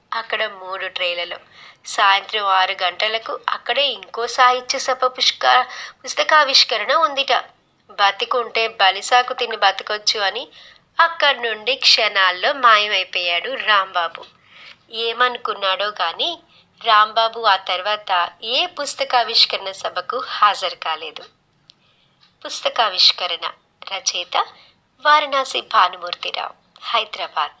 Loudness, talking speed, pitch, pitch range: -18 LUFS, 80 wpm, 220 Hz, 190-255 Hz